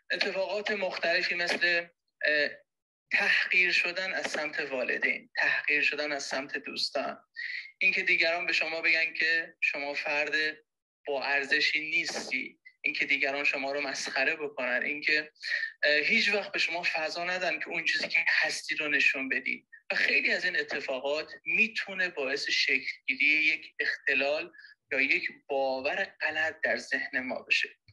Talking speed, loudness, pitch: 135 wpm, -28 LUFS, 175 Hz